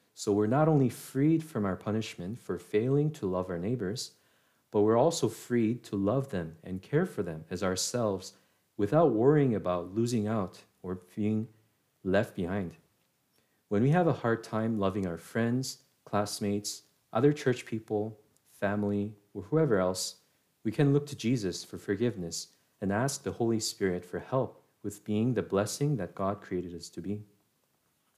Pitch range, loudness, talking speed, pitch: 95-125 Hz, -31 LUFS, 165 wpm, 105 Hz